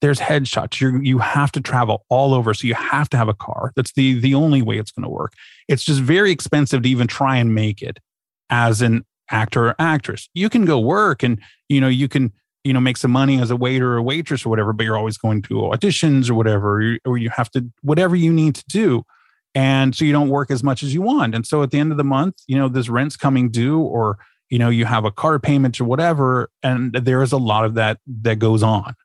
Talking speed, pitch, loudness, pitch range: 255 wpm, 130 Hz, -18 LUFS, 115-140 Hz